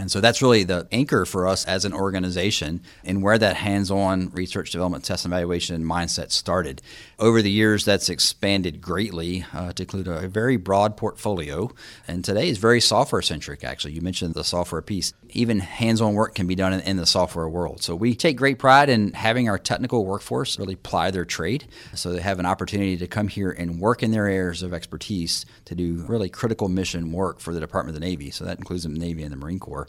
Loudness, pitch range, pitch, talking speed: -23 LUFS, 85-105 Hz, 95 Hz, 220 wpm